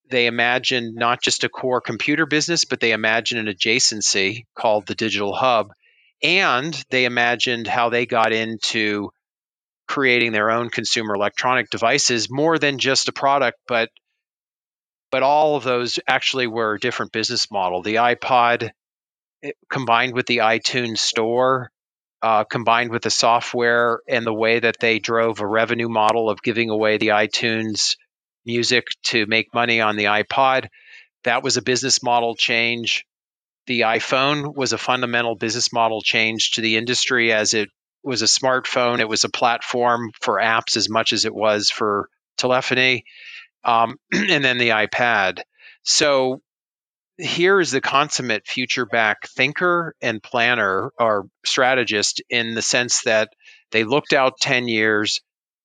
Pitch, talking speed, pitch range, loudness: 120 Hz, 150 wpm, 110-125 Hz, -19 LUFS